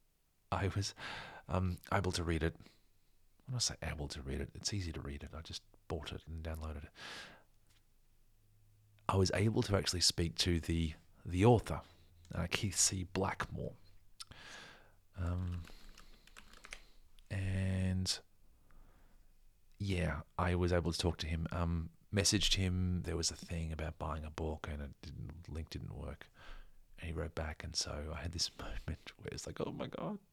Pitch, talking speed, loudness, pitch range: 90 Hz, 165 wpm, -38 LUFS, 80-100 Hz